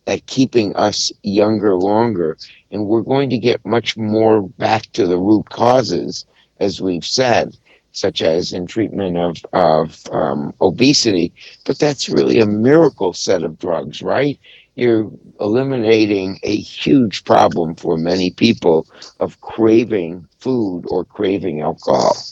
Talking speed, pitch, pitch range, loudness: 135 wpm, 110 Hz, 95-115 Hz, -16 LUFS